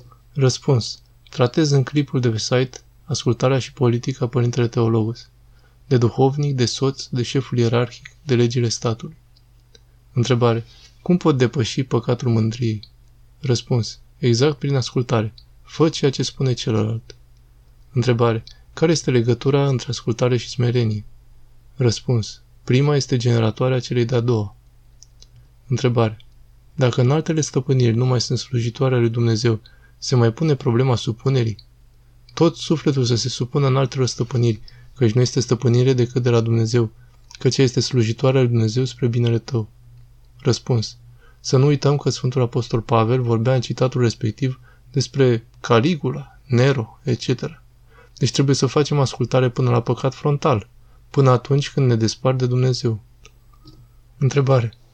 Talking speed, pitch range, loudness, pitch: 135 wpm, 120-130 Hz, -20 LUFS, 120 Hz